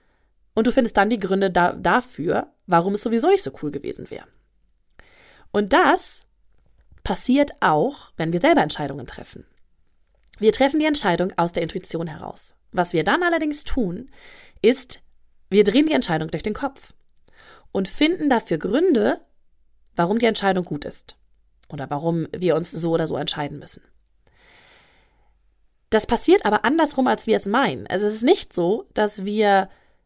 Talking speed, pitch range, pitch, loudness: 160 wpm, 170-275 Hz, 205 Hz, -20 LUFS